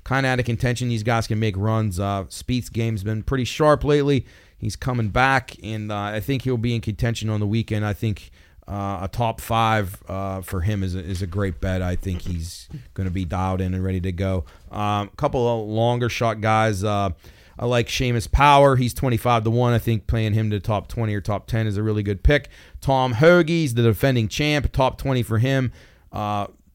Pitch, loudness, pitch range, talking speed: 110 Hz, -22 LUFS, 100-120 Hz, 225 wpm